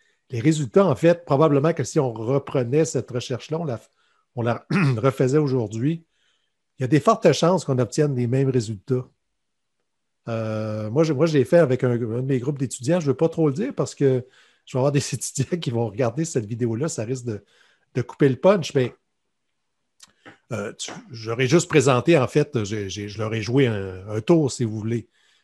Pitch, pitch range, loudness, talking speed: 135 Hz, 120-155 Hz, -22 LUFS, 205 wpm